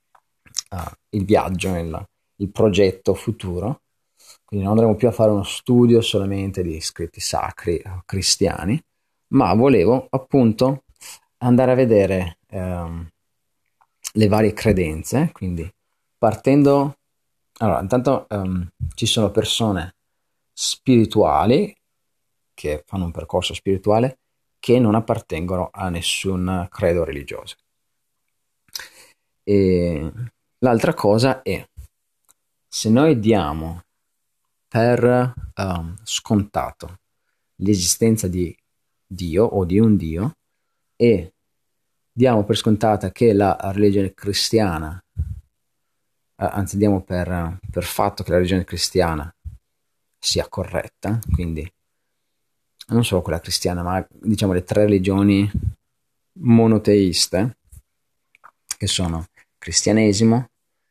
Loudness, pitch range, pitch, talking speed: -19 LUFS, 90-115 Hz, 100 Hz, 100 wpm